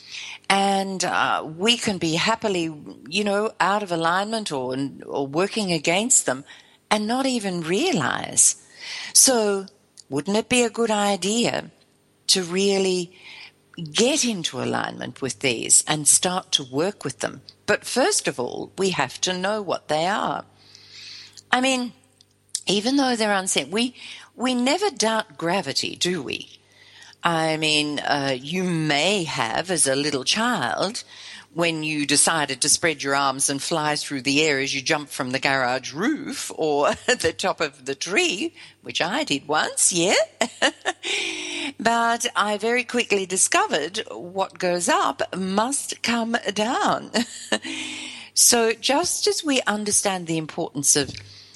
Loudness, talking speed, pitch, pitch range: -22 LUFS, 145 wpm, 190 Hz, 150-235 Hz